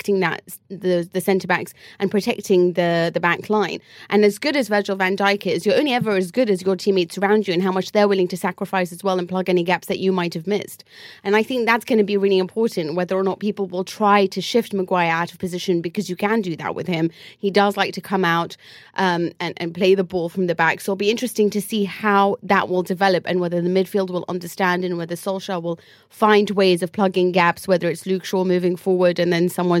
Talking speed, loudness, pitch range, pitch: 250 wpm, -20 LUFS, 180-200 Hz, 190 Hz